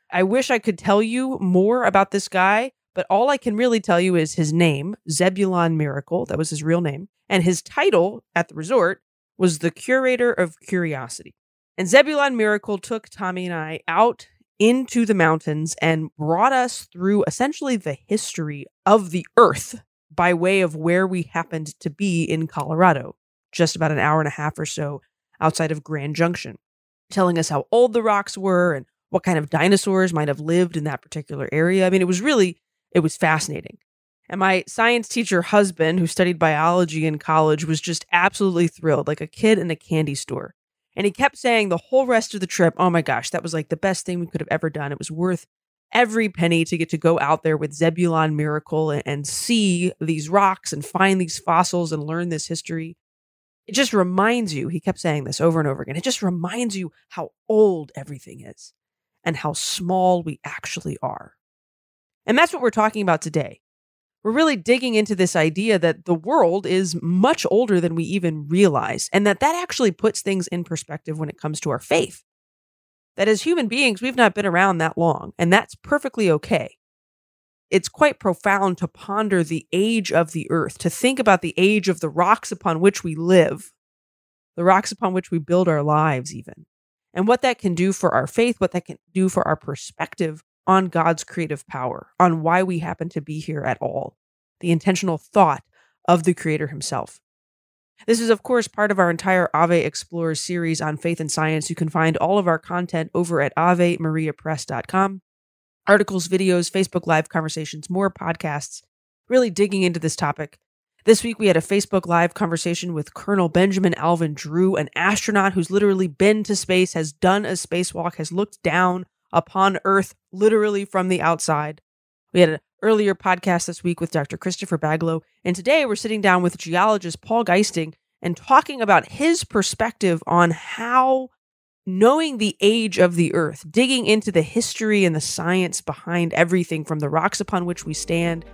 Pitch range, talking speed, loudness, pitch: 160-200 Hz, 190 wpm, -20 LUFS, 175 Hz